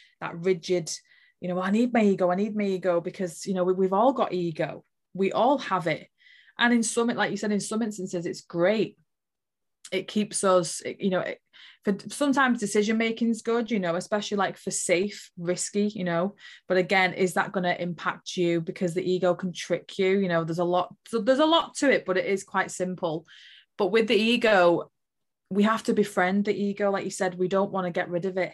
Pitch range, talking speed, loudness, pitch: 180-210 Hz, 225 wpm, -26 LUFS, 190 Hz